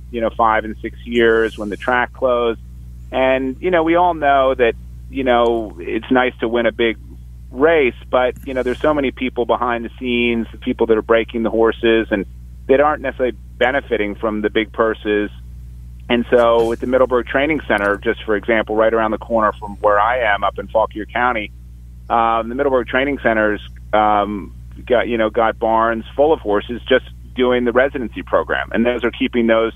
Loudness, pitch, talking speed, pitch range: -17 LUFS, 115 Hz, 200 wpm, 105-125 Hz